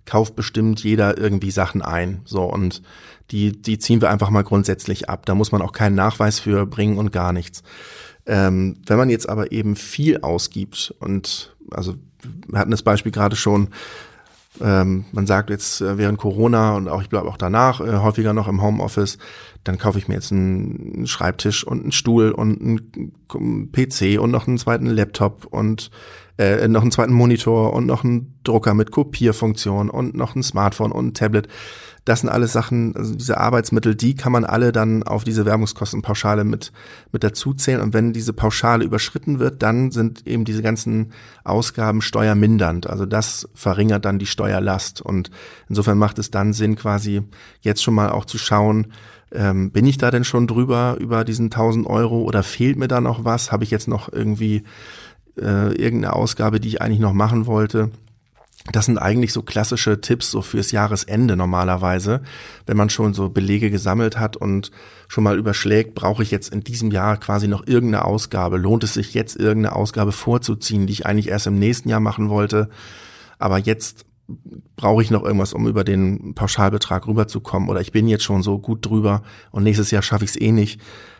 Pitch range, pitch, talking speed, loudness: 100-115 Hz, 105 Hz, 185 wpm, -19 LUFS